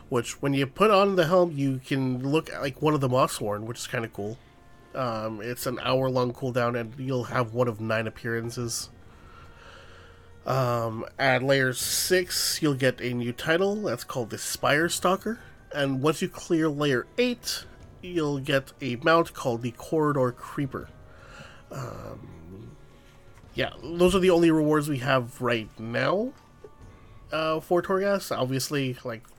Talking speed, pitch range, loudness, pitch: 155 wpm, 115-155 Hz, -26 LUFS, 130 Hz